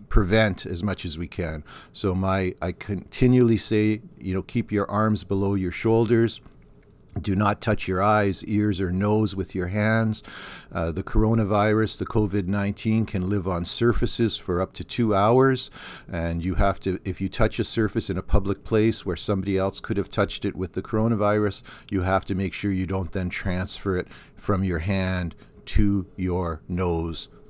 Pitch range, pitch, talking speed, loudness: 95-110 Hz, 100 Hz, 185 wpm, -24 LUFS